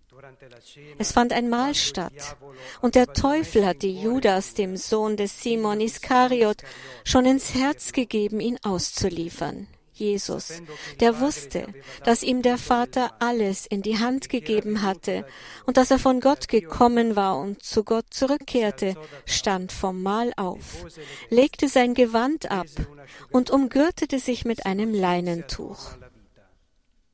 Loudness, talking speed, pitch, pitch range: -23 LUFS, 130 wpm, 215 Hz, 180-250 Hz